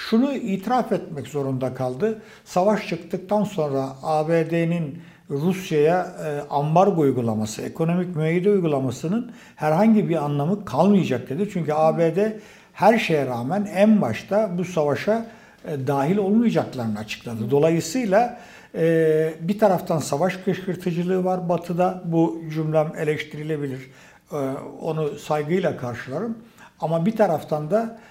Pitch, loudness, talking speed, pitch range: 170 Hz, -22 LUFS, 105 wpm, 150-205 Hz